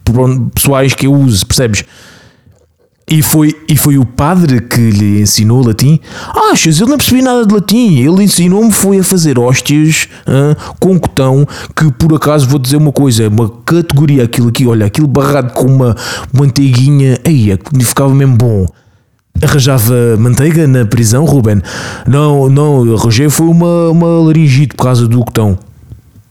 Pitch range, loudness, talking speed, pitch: 120-155 Hz, -8 LUFS, 160 wpm, 135 Hz